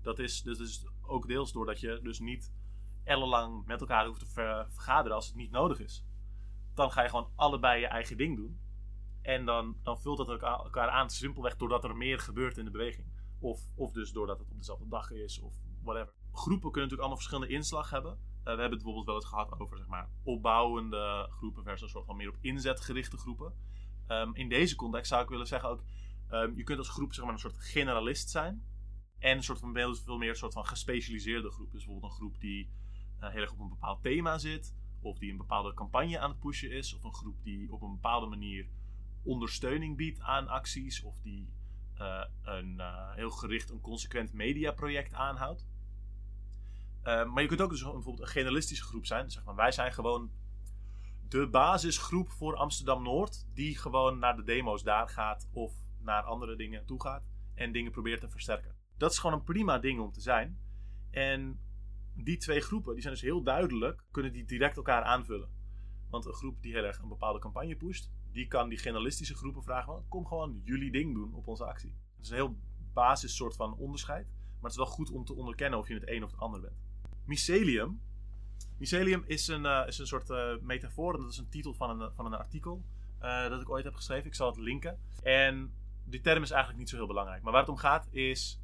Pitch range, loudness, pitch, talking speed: 100-130 Hz, -35 LUFS, 115 Hz, 215 wpm